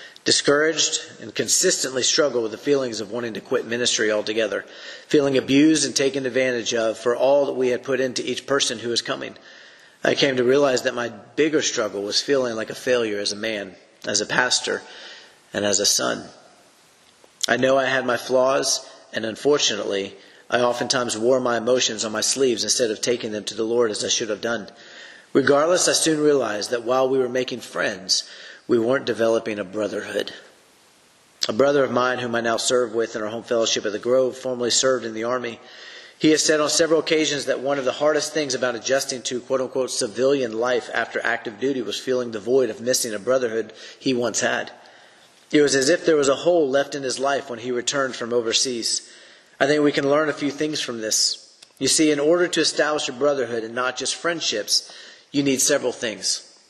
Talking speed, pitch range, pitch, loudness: 205 wpm, 120-140 Hz, 130 Hz, -21 LUFS